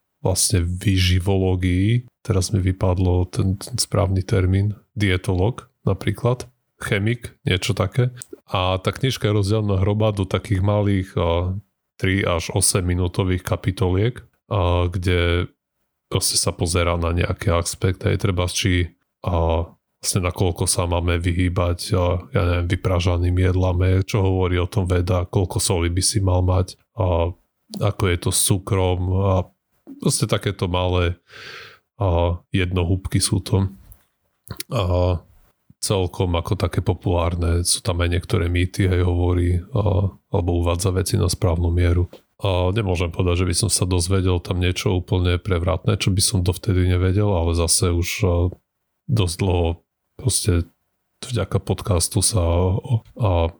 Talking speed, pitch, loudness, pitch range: 140 wpm, 95 Hz, -21 LUFS, 90-100 Hz